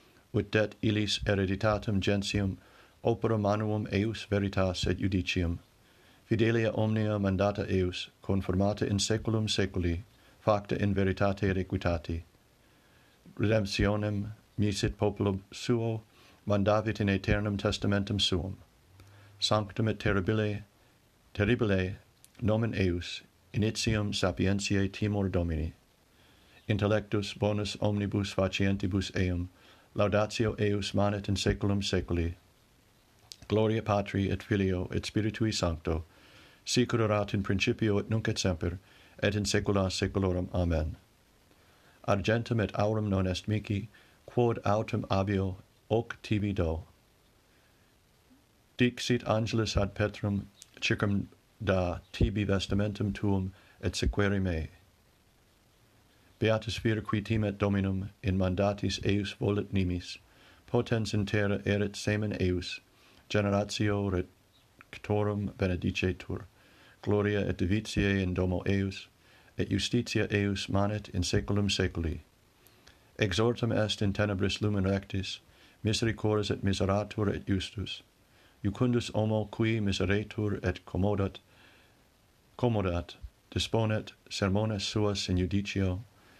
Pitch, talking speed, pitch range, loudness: 100 Hz, 105 wpm, 95-110 Hz, -31 LUFS